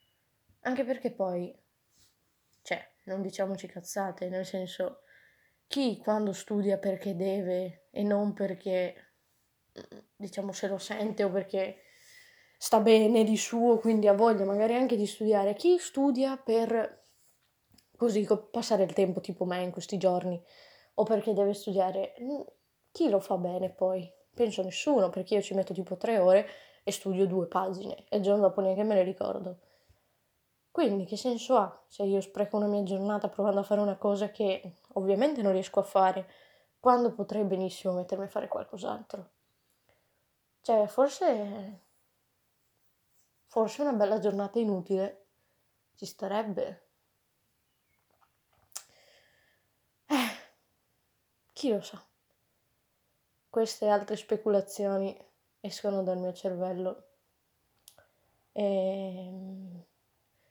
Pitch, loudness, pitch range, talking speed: 200 Hz, -30 LUFS, 190-220 Hz, 125 wpm